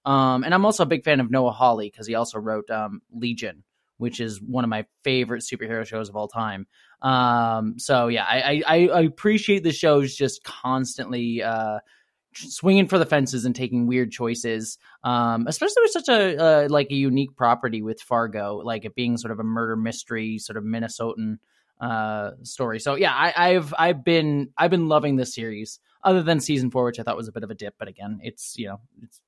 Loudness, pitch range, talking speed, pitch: -23 LUFS, 115-145 Hz, 210 wpm, 120 Hz